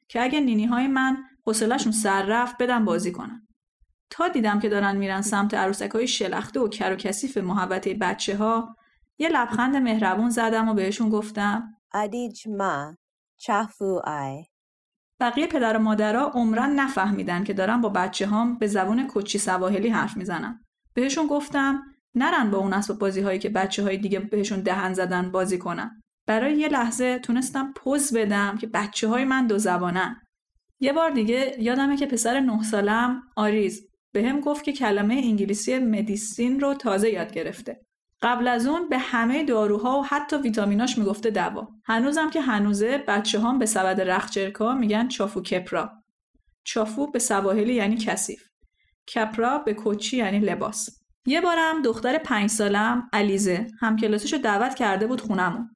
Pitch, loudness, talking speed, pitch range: 225 Hz, -24 LUFS, 155 wpm, 205-250 Hz